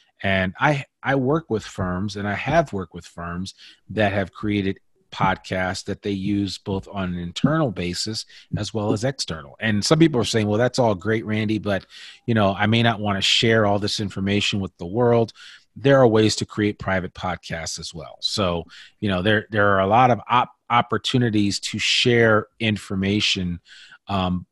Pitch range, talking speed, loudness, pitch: 95-110 Hz, 190 wpm, -21 LUFS, 105 Hz